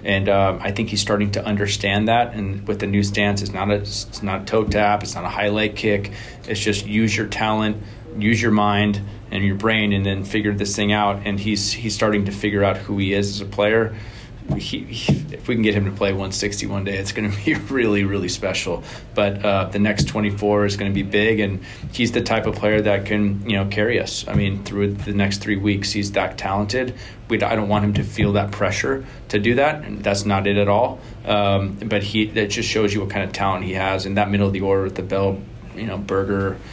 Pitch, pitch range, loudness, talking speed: 105 Hz, 100-110 Hz, -21 LUFS, 250 wpm